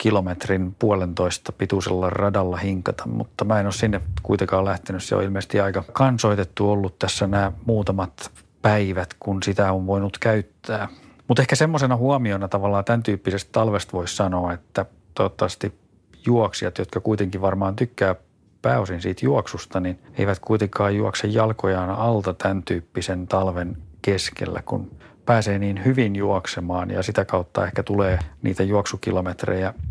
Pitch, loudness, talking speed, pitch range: 100 Hz, -23 LUFS, 140 wpm, 95-105 Hz